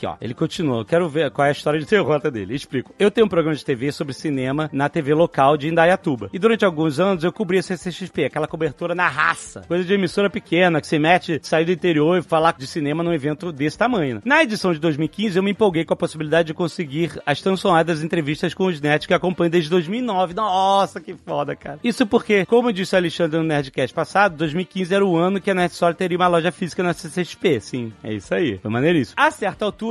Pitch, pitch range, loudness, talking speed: 175 Hz, 155-190 Hz, -20 LUFS, 235 wpm